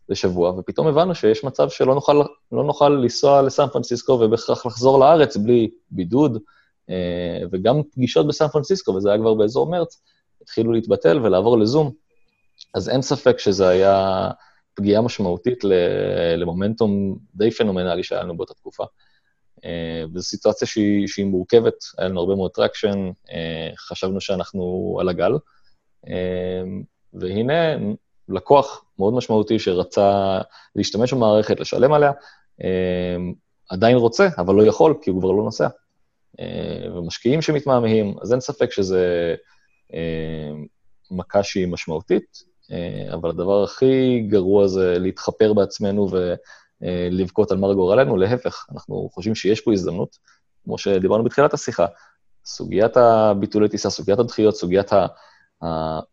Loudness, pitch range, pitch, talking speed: -19 LUFS, 90-120 Hz, 100 Hz, 125 wpm